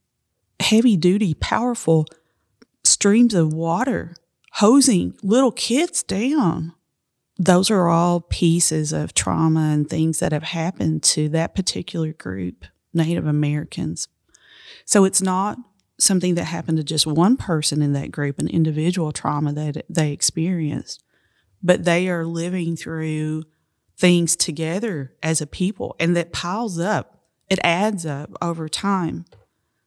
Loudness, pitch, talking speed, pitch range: -20 LUFS, 165 Hz, 130 wpm, 155-185 Hz